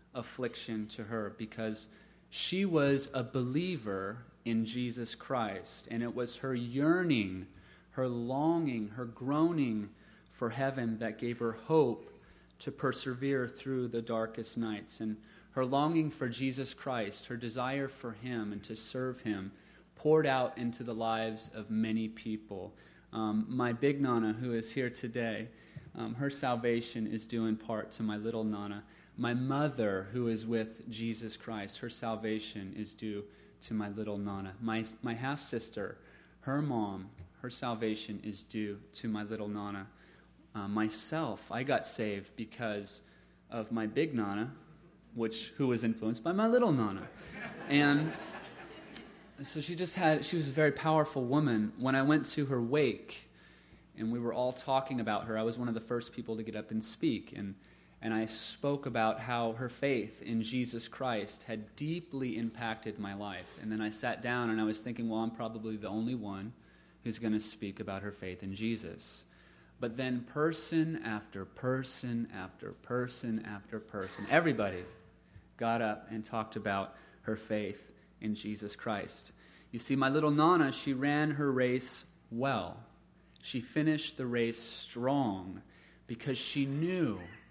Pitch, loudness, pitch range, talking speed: 115 Hz, -35 LUFS, 110-130 Hz, 160 wpm